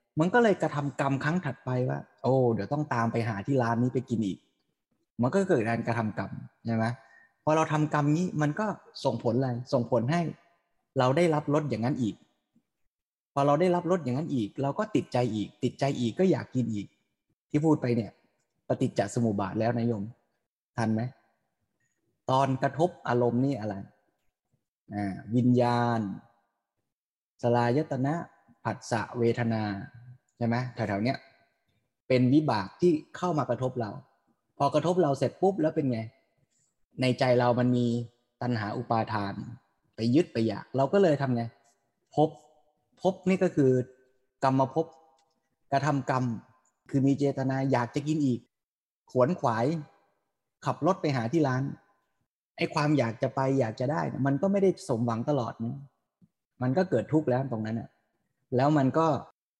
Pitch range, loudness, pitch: 115-150 Hz, -28 LUFS, 130 Hz